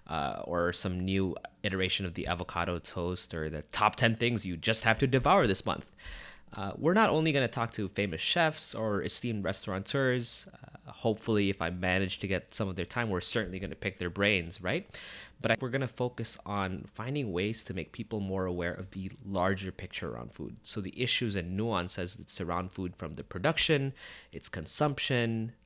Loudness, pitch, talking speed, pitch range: -31 LUFS, 100 Hz, 195 wpm, 90-120 Hz